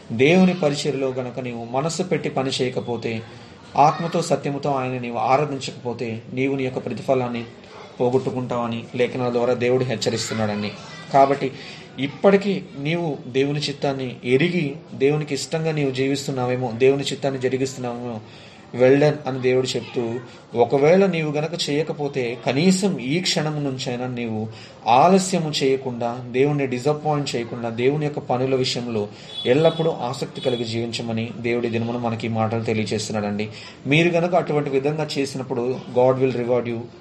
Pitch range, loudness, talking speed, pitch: 120-145 Hz, -22 LUFS, 120 wpm, 130 Hz